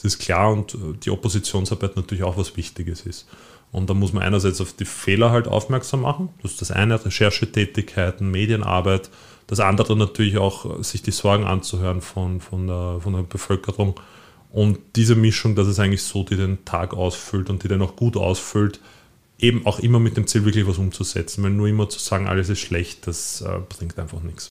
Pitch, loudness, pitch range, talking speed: 100 Hz, -21 LUFS, 95-110 Hz, 195 wpm